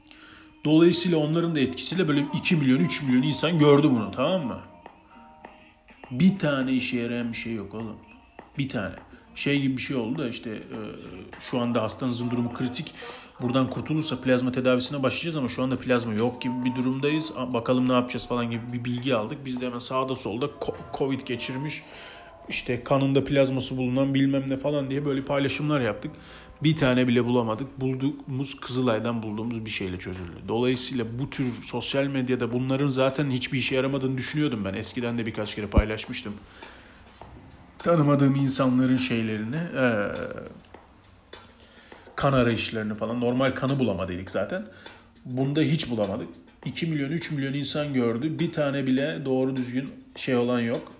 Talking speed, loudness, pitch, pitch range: 150 wpm, -26 LUFS, 130 Hz, 120-140 Hz